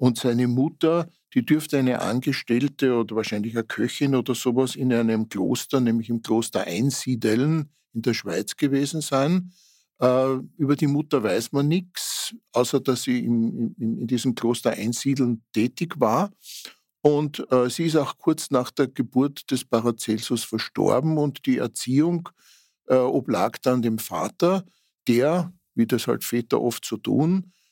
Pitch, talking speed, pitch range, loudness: 130 Hz, 145 wpm, 120-155 Hz, -24 LUFS